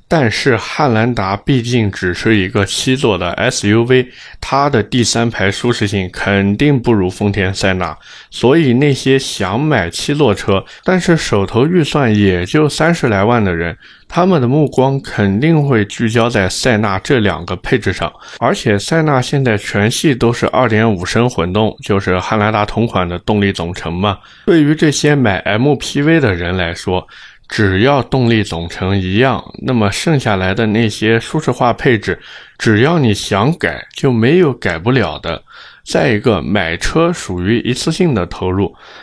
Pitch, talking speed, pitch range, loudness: 115 Hz, 245 characters per minute, 100-135 Hz, -14 LUFS